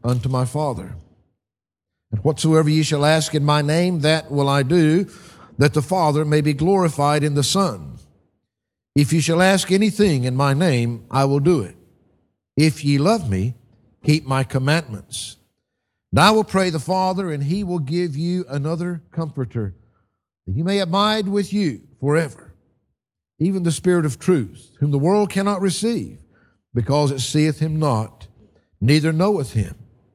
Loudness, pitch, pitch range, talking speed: -19 LUFS, 150 Hz, 120-175 Hz, 160 wpm